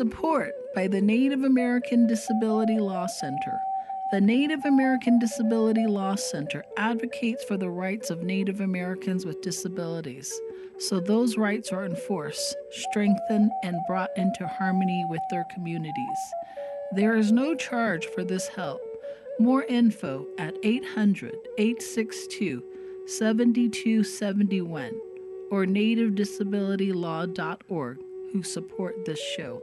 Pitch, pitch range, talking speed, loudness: 215 Hz, 190-255 Hz, 110 wpm, -27 LUFS